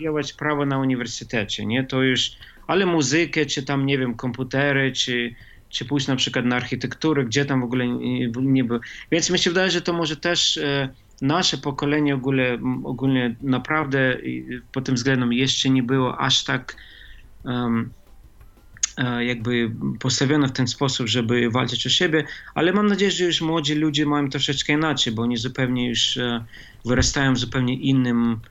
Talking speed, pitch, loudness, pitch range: 155 wpm, 130 Hz, -22 LUFS, 120-145 Hz